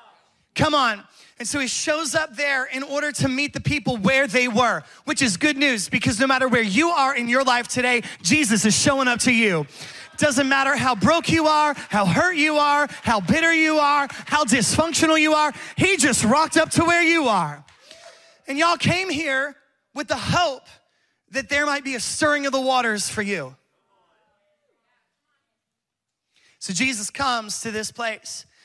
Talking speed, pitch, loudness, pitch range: 180 wpm, 275 Hz, -20 LUFS, 240-300 Hz